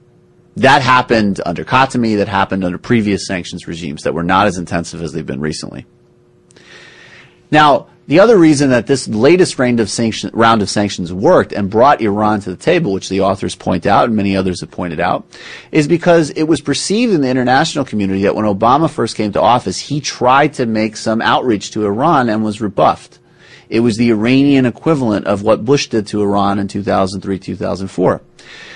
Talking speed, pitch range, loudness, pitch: 190 wpm, 95-125 Hz, -14 LUFS, 105 Hz